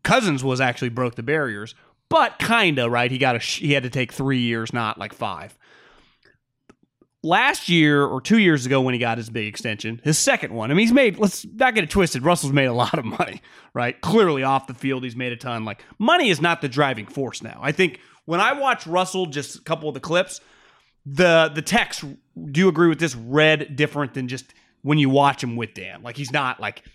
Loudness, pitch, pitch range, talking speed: -21 LUFS, 140 Hz, 125-170 Hz, 225 wpm